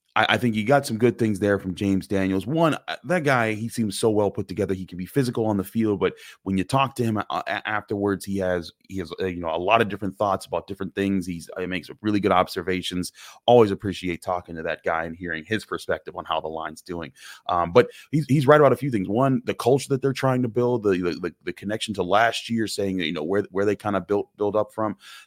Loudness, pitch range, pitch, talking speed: -24 LUFS, 95-115 Hz, 105 Hz, 250 wpm